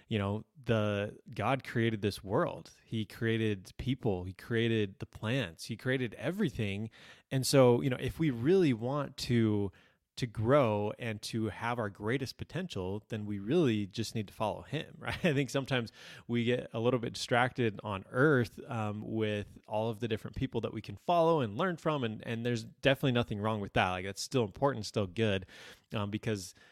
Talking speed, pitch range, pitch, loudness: 190 wpm, 105-130 Hz, 115 Hz, -33 LUFS